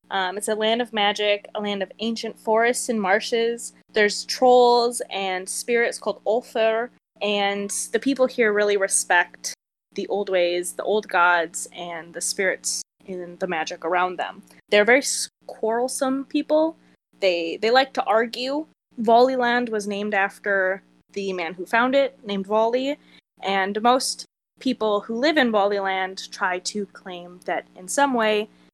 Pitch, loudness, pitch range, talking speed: 210 Hz, -22 LUFS, 190-240 Hz, 150 wpm